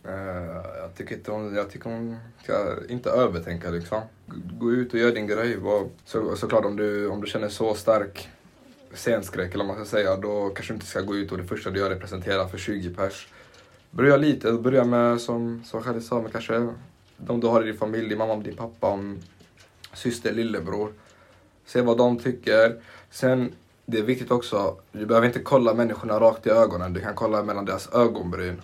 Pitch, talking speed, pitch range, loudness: 110 Hz, 200 wpm, 100-115 Hz, -25 LUFS